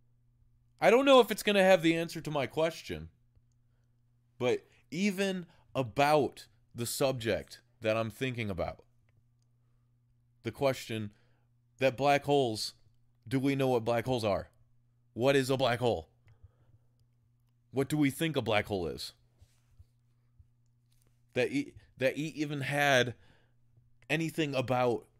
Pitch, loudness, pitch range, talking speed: 120 Hz, -30 LUFS, 120-135 Hz, 130 wpm